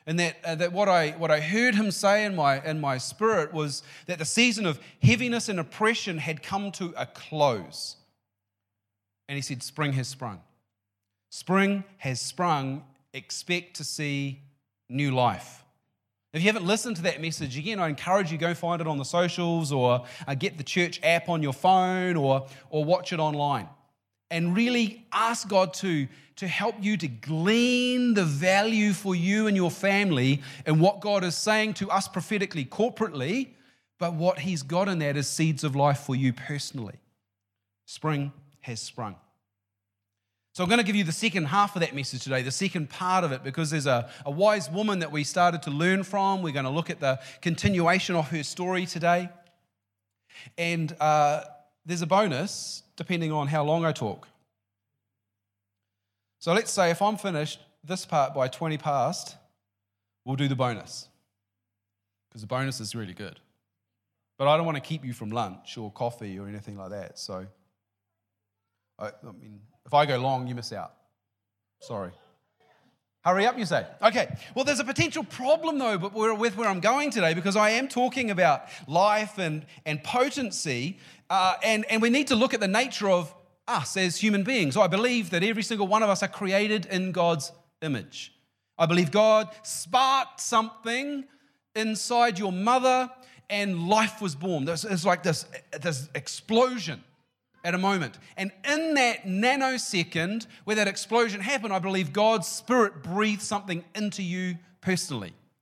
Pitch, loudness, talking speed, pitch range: 170 Hz, -26 LUFS, 175 wpm, 135-200 Hz